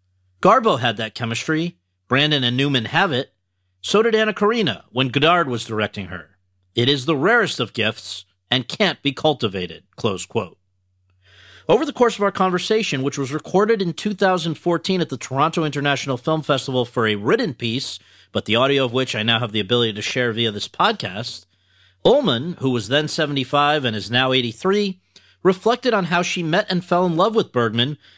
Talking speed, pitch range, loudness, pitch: 185 wpm, 110-170 Hz, -20 LUFS, 130 Hz